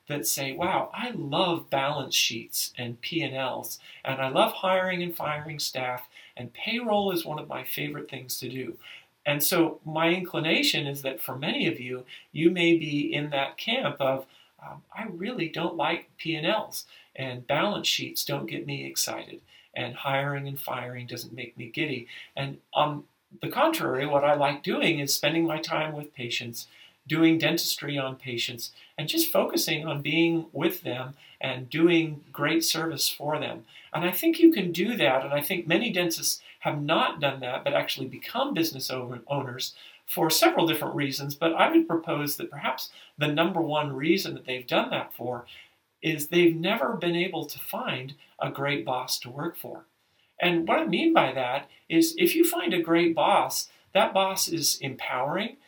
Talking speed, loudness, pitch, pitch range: 180 wpm, -27 LUFS, 155 Hz, 135-170 Hz